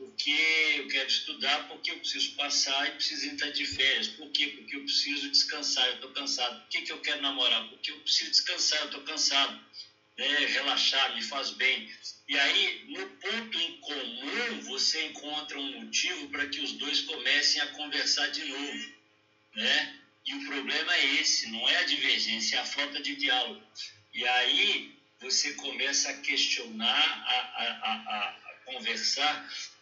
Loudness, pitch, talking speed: -28 LUFS, 150 Hz, 170 wpm